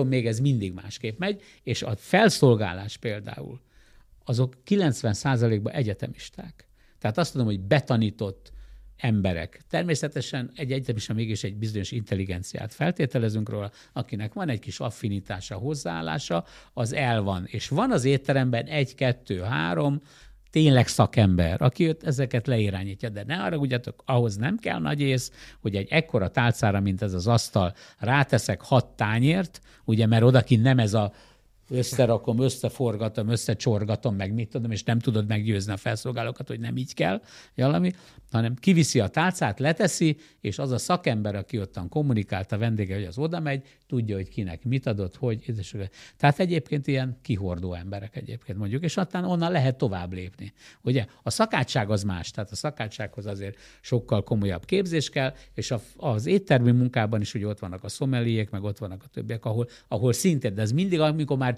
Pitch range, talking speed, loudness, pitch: 105-135 Hz, 160 wpm, -26 LUFS, 120 Hz